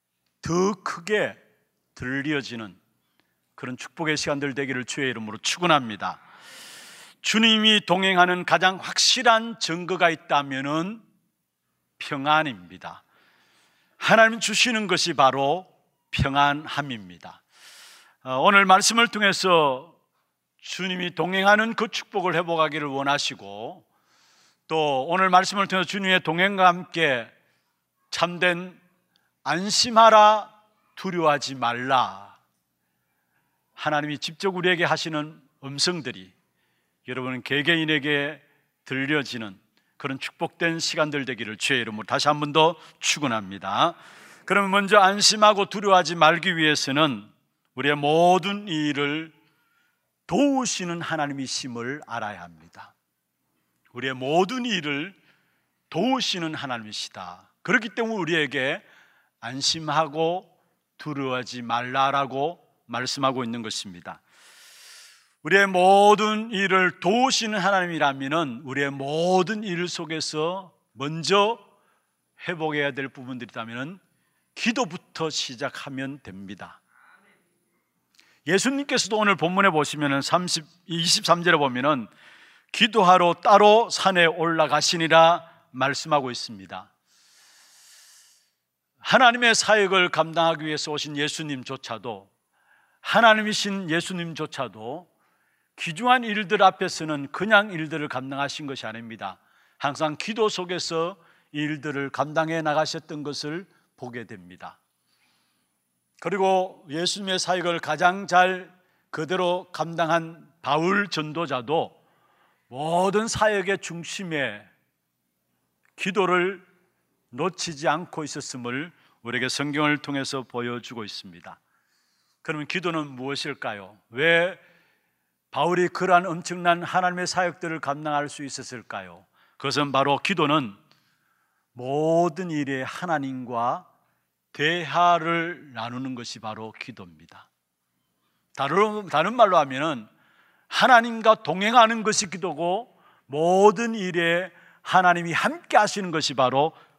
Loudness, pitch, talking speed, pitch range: -23 LUFS, 160 Hz, 255 characters per minute, 135-185 Hz